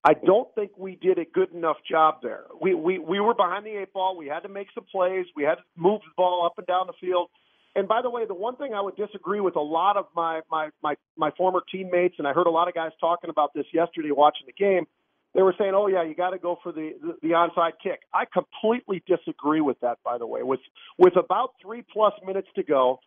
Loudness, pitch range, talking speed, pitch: -25 LUFS, 165-200 Hz, 260 wpm, 185 Hz